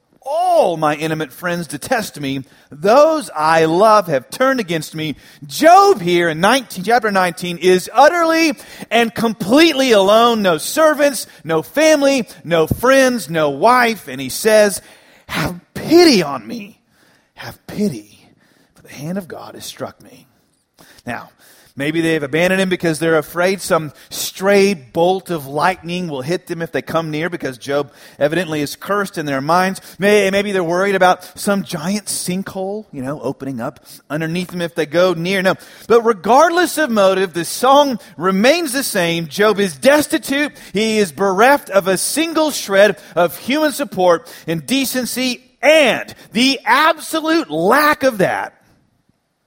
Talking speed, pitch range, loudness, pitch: 150 wpm, 165-255 Hz, -15 LUFS, 190 Hz